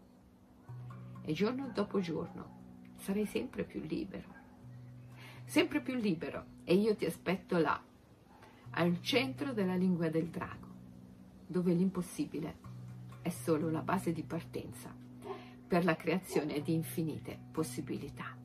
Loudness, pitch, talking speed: -36 LUFS, 150 Hz, 115 wpm